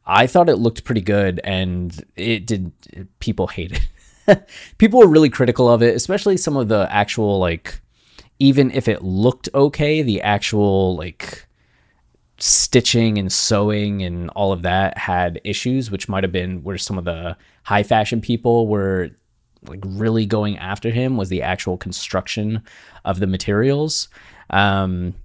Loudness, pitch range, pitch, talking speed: -18 LUFS, 90-115 Hz, 100 Hz, 155 wpm